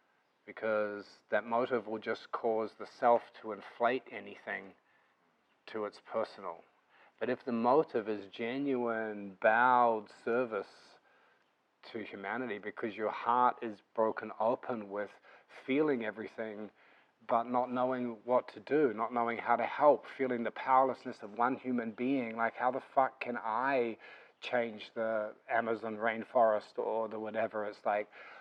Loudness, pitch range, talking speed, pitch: -34 LUFS, 110-125 Hz, 140 wpm, 115 Hz